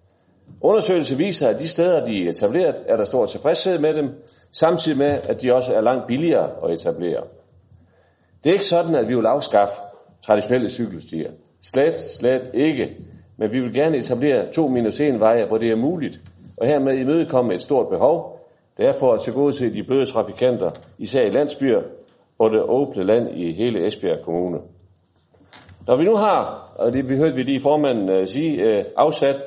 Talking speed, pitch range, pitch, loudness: 185 wpm, 100-150 Hz, 125 Hz, -20 LUFS